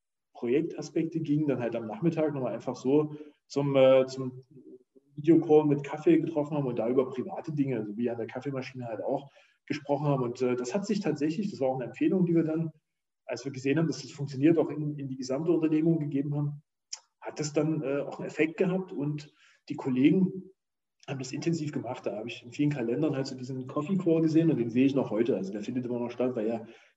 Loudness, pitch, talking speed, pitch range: -29 LUFS, 145 Hz, 225 wpm, 130-160 Hz